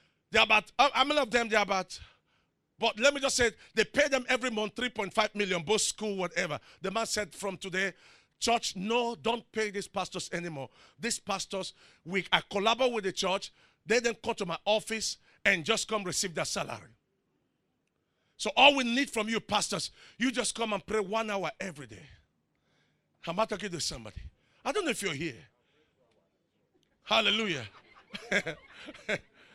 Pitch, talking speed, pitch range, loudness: 210 Hz, 175 wpm, 190-230 Hz, -30 LUFS